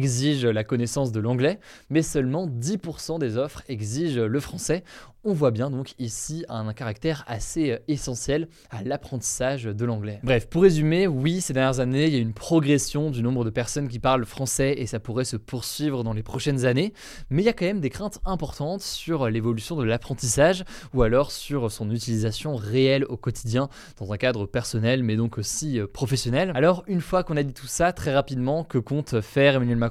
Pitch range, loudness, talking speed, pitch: 120-155 Hz, -25 LUFS, 195 wpm, 135 Hz